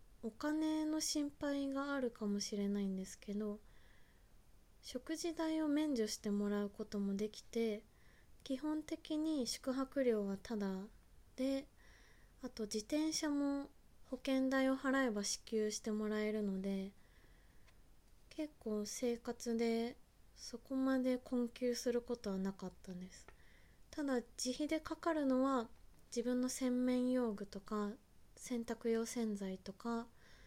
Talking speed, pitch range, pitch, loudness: 235 characters per minute, 215-270 Hz, 240 Hz, -40 LUFS